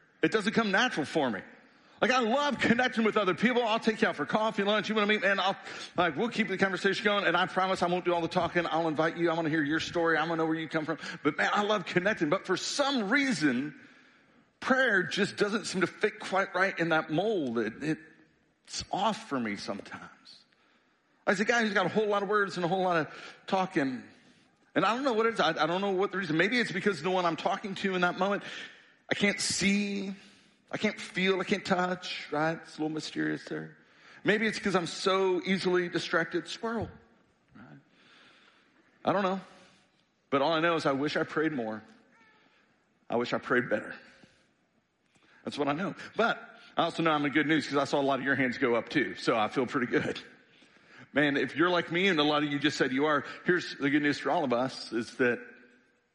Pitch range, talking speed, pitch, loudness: 160-210 Hz, 240 wpm, 185 Hz, -29 LUFS